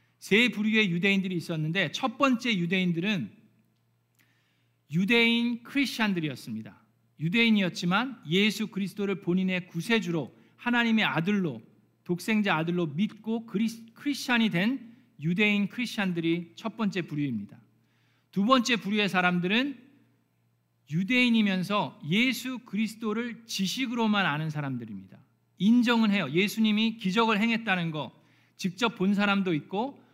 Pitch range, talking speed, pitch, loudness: 170-225 Hz, 305 characters per minute, 200 Hz, -27 LUFS